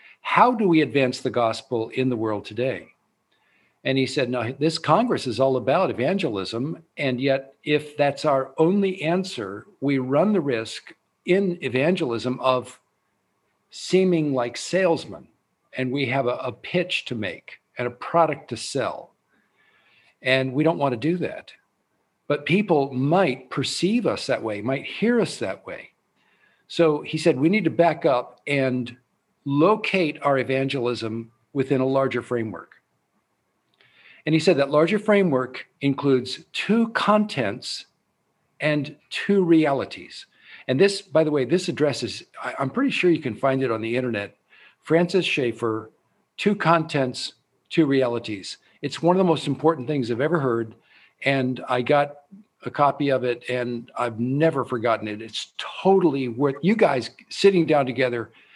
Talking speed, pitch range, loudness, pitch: 155 wpm, 125-170 Hz, -23 LUFS, 140 Hz